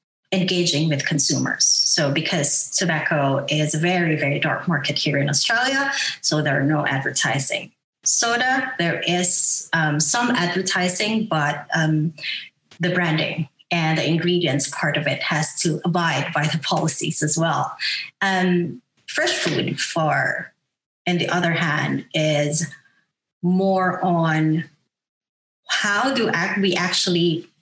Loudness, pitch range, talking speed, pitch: -20 LUFS, 150-180 Hz, 130 wpm, 165 Hz